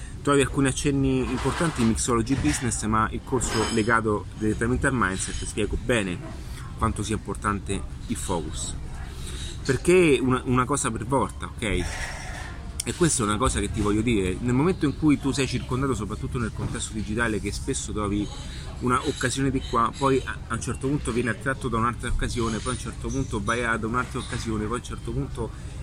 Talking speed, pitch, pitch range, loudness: 185 wpm, 115 Hz, 105-130 Hz, -26 LUFS